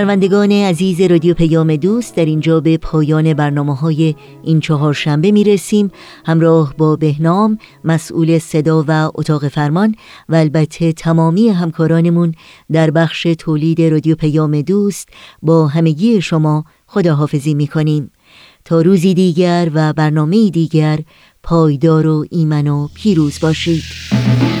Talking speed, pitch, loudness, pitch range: 125 wpm, 160 Hz, -13 LUFS, 155-175 Hz